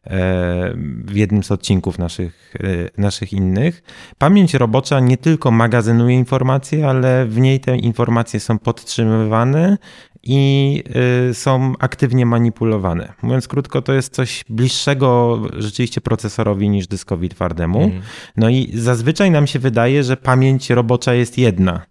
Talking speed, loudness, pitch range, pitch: 125 wpm, -16 LUFS, 105-130 Hz, 120 Hz